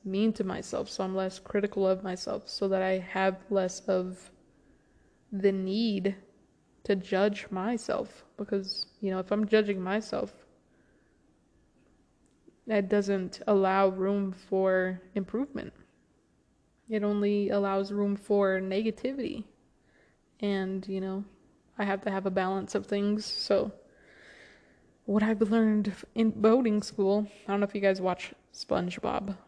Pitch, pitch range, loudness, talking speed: 200 Hz, 190-210 Hz, -30 LUFS, 130 wpm